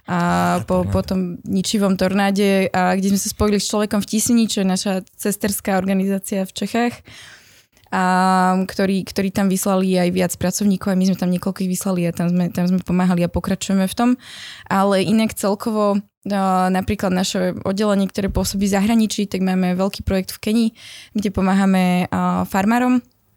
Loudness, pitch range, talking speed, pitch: -19 LUFS, 185-205 Hz, 165 wpm, 195 Hz